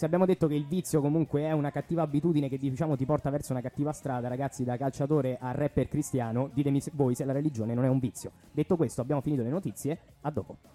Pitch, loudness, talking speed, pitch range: 145 Hz, -30 LUFS, 235 wpm, 130-155 Hz